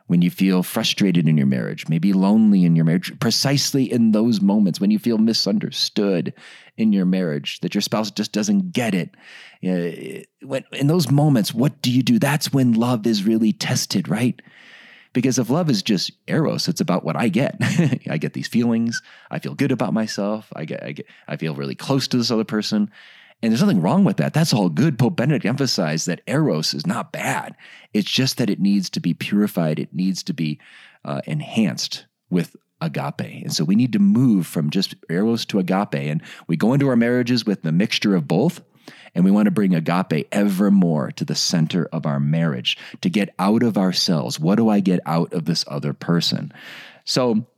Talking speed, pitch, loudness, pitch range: 200 wpm, 110 Hz, -20 LUFS, 90-130 Hz